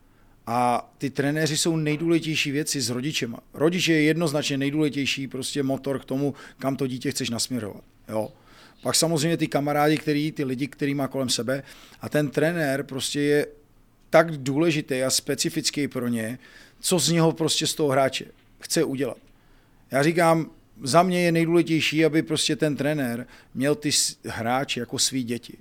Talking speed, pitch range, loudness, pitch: 160 wpm, 130-155 Hz, -24 LUFS, 145 Hz